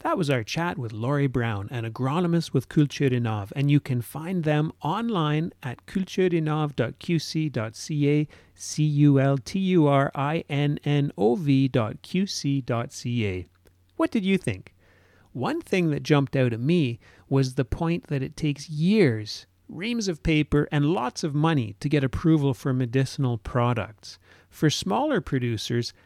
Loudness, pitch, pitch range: -25 LUFS, 140 Hz, 120-160 Hz